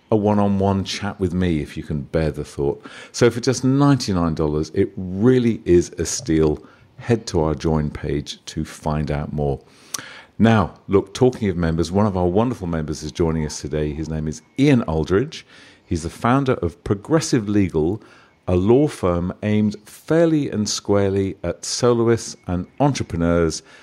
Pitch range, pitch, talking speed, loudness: 80-115 Hz, 90 Hz, 165 wpm, -20 LUFS